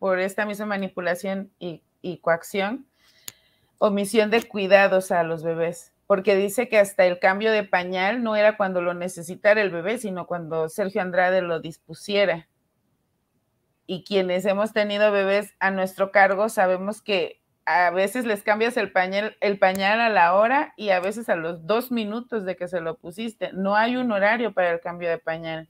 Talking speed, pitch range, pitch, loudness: 175 wpm, 180-210 Hz, 195 Hz, -23 LUFS